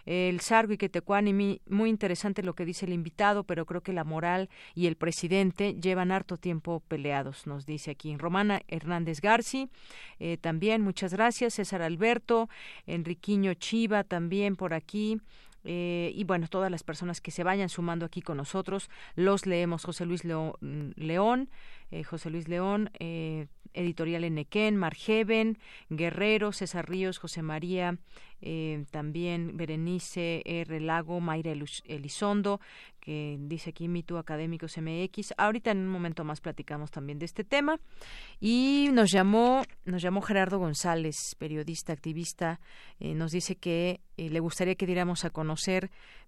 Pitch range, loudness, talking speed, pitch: 165-200 Hz, -31 LUFS, 150 wpm, 175 Hz